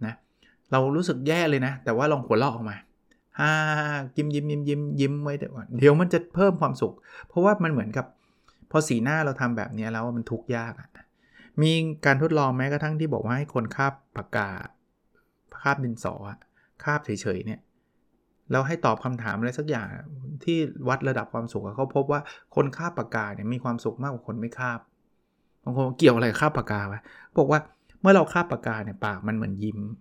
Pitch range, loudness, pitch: 115-150 Hz, -26 LUFS, 135 Hz